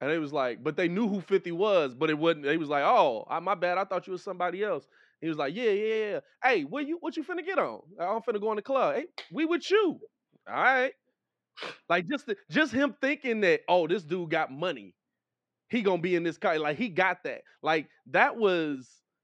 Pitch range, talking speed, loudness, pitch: 175-285 Hz, 240 wpm, -28 LUFS, 200 Hz